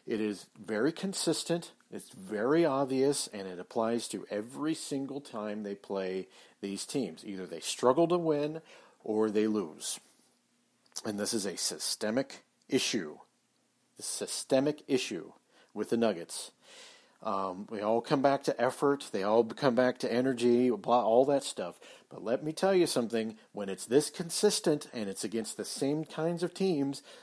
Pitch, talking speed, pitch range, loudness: 130 Hz, 160 wpm, 110-150 Hz, -31 LUFS